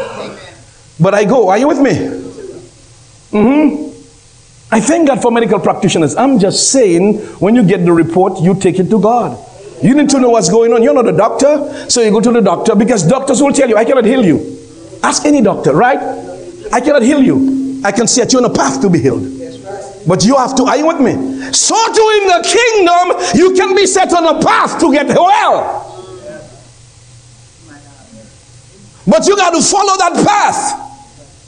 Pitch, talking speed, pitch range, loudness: 240 Hz, 195 wpm, 190-295 Hz, -10 LUFS